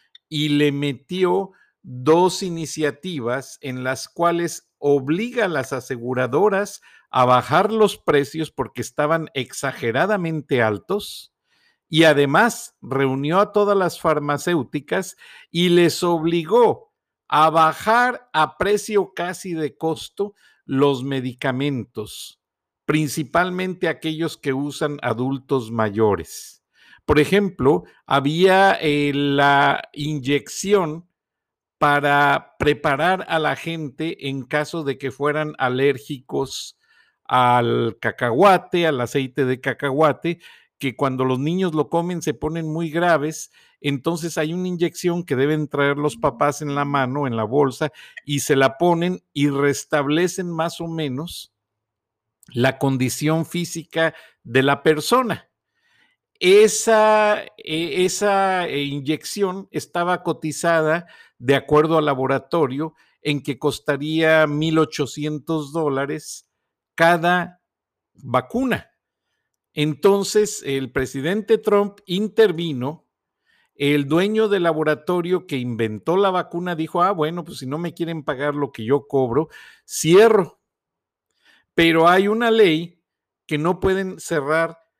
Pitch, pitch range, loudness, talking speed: 155 Hz, 140-180 Hz, -20 LUFS, 110 wpm